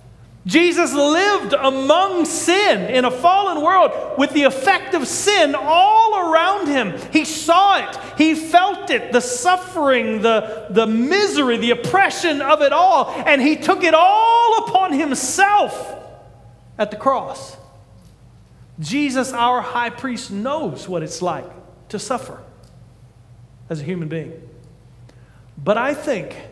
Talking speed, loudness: 135 wpm, -17 LUFS